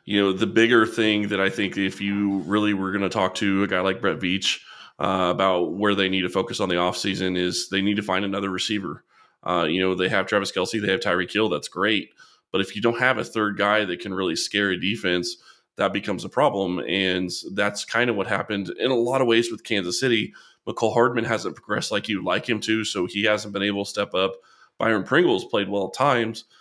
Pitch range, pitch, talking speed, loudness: 95-105 Hz, 100 Hz, 240 wpm, -23 LUFS